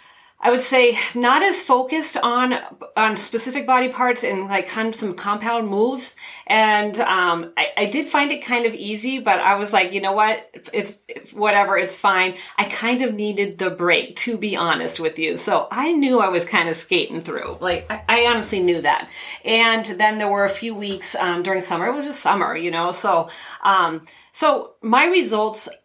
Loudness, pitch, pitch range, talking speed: -19 LUFS, 215 Hz, 195-255 Hz, 205 wpm